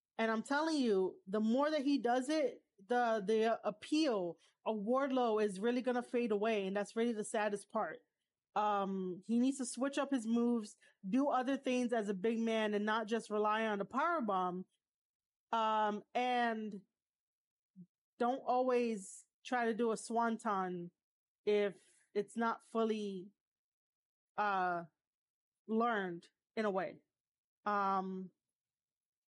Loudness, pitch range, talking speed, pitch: -37 LUFS, 200-240 Hz, 140 wpm, 220 Hz